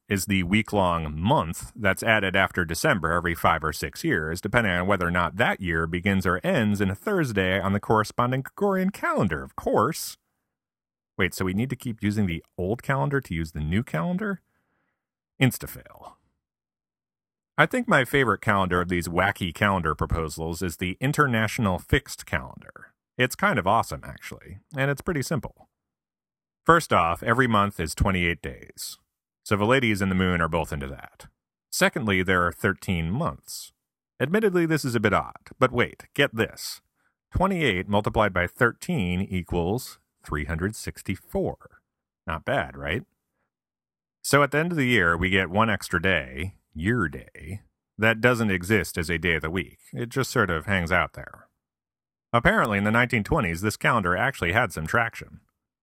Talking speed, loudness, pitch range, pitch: 165 wpm, -24 LUFS, 90-120 Hz, 100 Hz